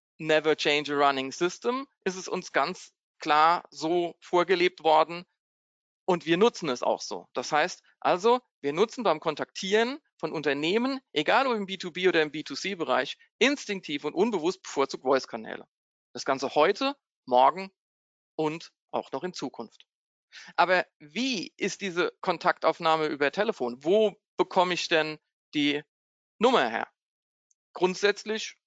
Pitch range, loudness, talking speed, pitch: 155-205 Hz, -27 LUFS, 135 wpm, 175 Hz